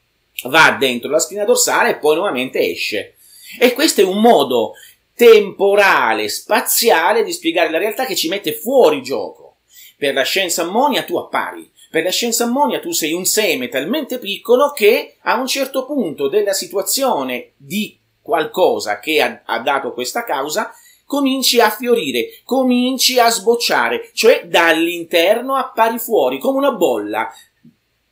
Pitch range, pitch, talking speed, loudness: 200-295 Hz, 245 Hz, 145 wpm, -15 LUFS